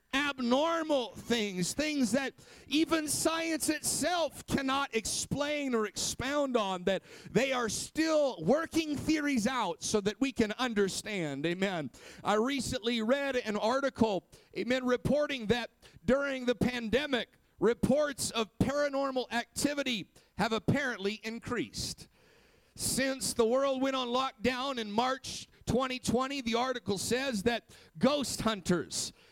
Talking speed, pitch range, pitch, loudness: 120 wpm, 220-275 Hz, 250 Hz, -32 LUFS